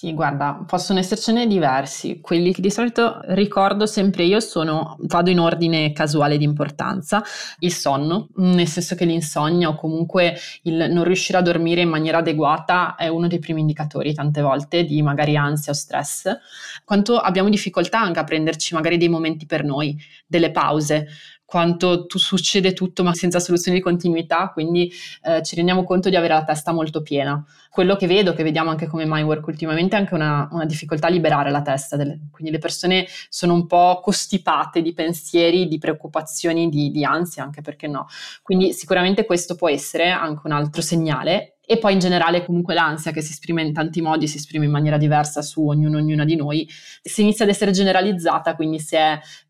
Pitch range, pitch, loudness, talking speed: 155-180 Hz, 165 Hz, -19 LUFS, 190 wpm